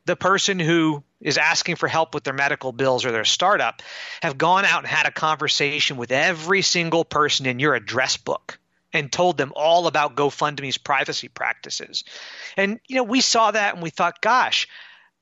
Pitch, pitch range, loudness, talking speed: 160 Hz, 145-180 Hz, -20 LUFS, 185 wpm